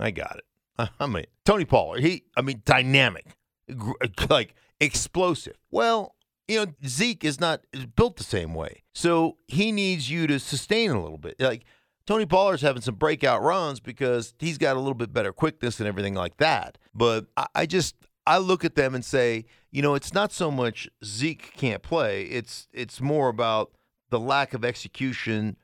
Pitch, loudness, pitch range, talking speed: 135 Hz, -25 LUFS, 120-165 Hz, 185 wpm